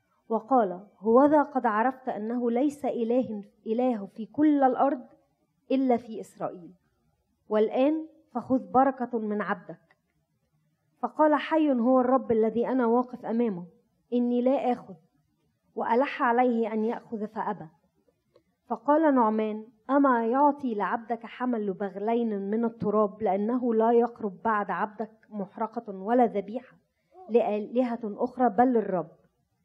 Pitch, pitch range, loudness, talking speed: 235 Hz, 215-255 Hz, -27 LUFS, 115 wpm